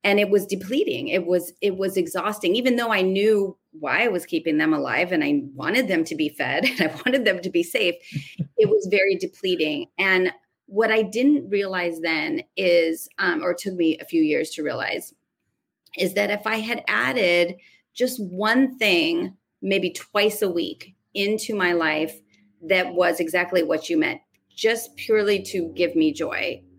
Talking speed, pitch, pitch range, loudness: 180 wpm, 195 Hz, 175-230 Hz, -22 LUFS